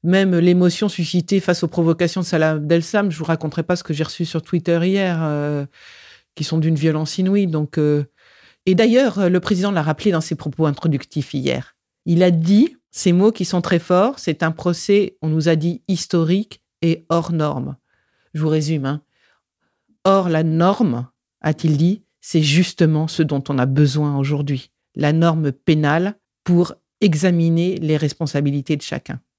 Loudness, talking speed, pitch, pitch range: -18 LUFS, 175 wpm, 165 Hz, 155-185 Hz